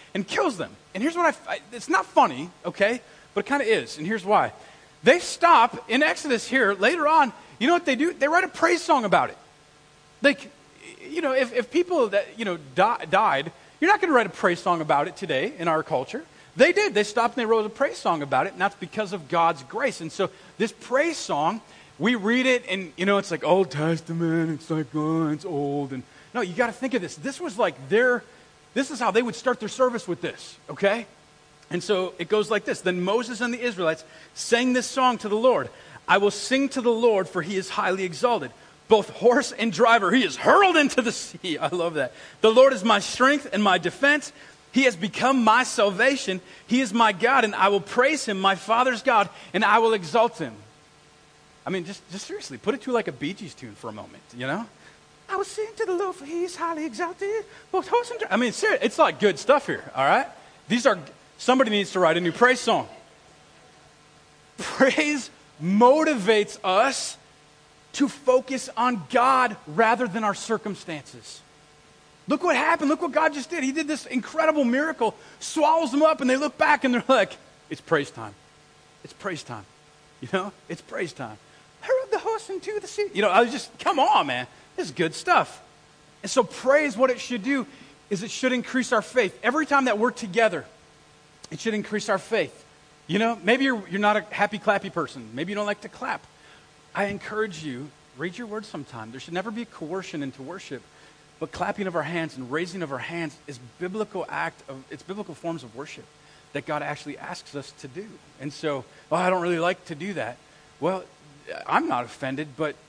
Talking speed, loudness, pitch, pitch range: 215 wpm, -23 LUFS, 215 Hz, 170-265 Hz